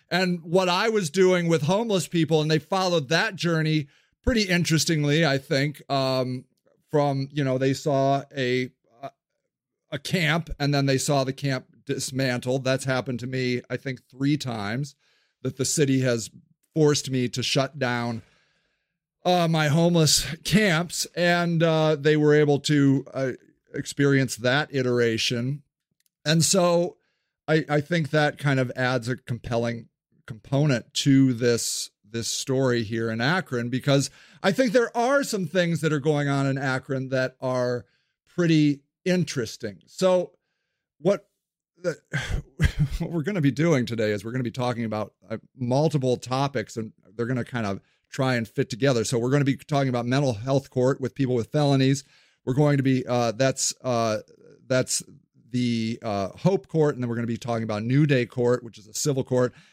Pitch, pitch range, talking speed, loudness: 135 Hz, 125-155 Hz, 170 wpm, -24 LUFS